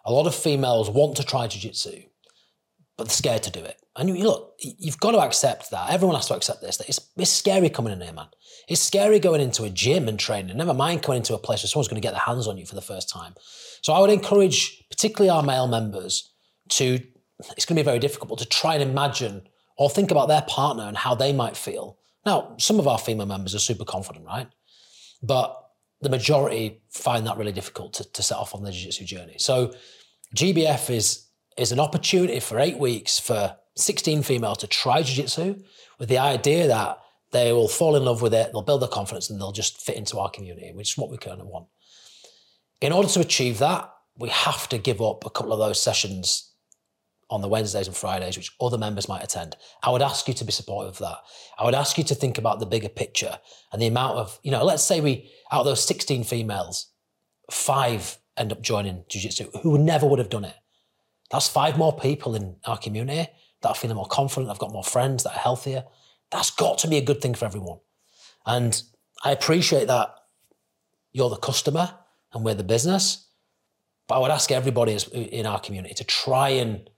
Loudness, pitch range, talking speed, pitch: -23 LUFS, 110-145 Hz, 215 wpm, 125 Hz